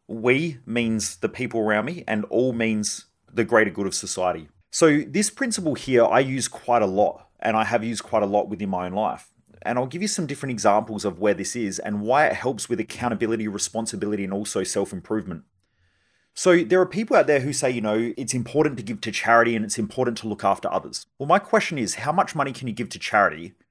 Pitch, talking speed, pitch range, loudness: 115 Hz, 230 wpm, 105-130 Hz, -23 LUFS